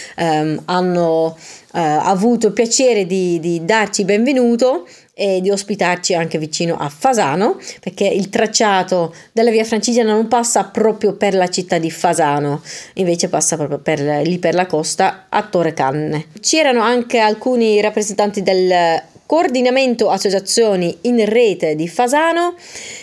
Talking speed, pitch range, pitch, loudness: 140 wpm, 170-225 Hz, 195 Hz, -15 LUFS